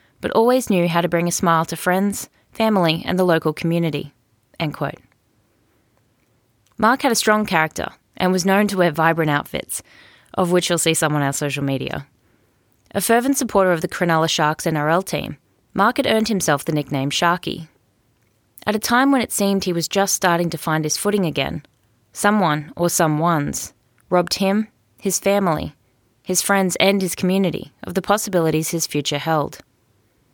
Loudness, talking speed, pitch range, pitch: -19 LUFS, 175 wpm, 145-195 Hz, 170 Hz